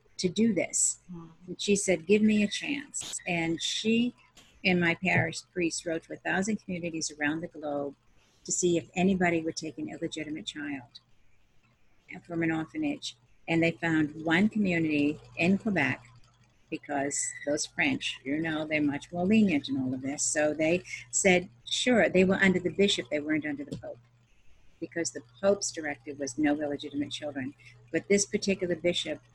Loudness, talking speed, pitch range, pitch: -29 LUFS, 170 wpm, 145-180 Hz, 160 Hz